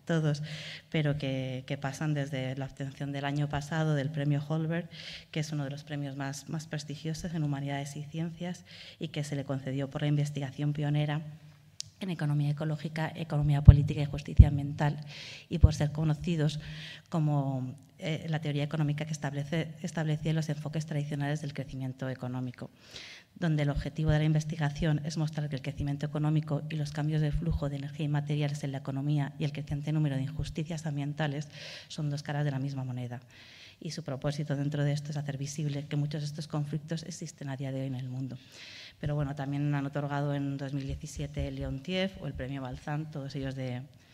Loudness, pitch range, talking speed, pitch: -32 LUFS, 140-155 Hz, 190 wpm, 145 Hz